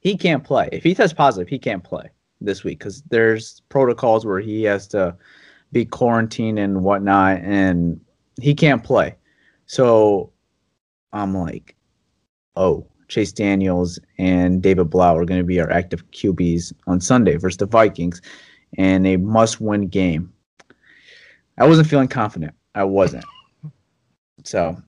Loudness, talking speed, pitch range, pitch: -18 LUFS, 140 wpm, 90-115 Hz, 100 Hz